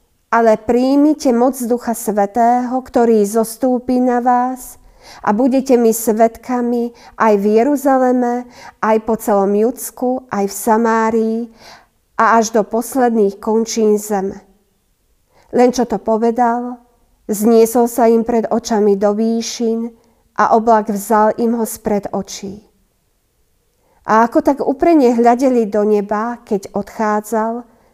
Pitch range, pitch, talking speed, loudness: 215-245 Hz, 230 Hz, 120 wpm, -15 LUFS